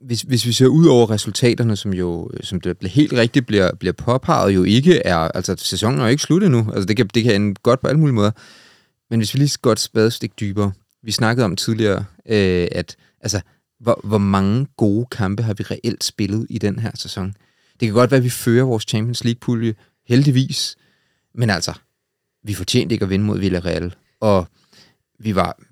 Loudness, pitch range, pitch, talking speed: -18 LUFS, 100-125 Hz, 110 Hz, 210 wpm